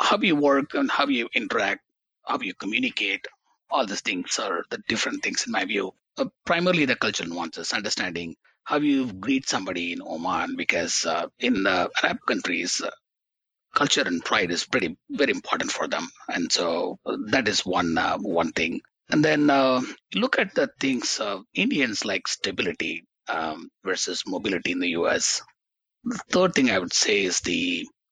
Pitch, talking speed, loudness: 245 Hz, 175 wpm, -24 LUFS